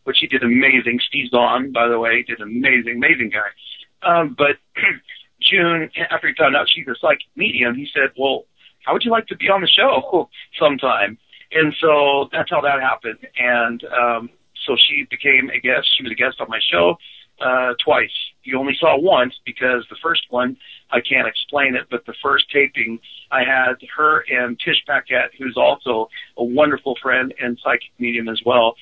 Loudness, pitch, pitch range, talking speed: -17 LUFS, 125 Hz, 120-150 Hz, 190 wpm